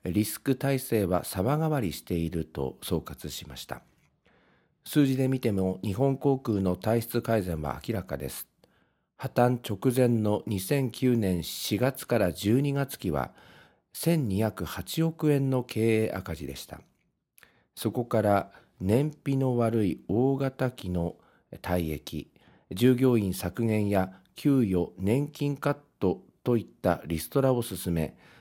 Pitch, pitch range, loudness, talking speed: 110 Hz, 90-130 Hz, -28 LUFS, 220 characters per minute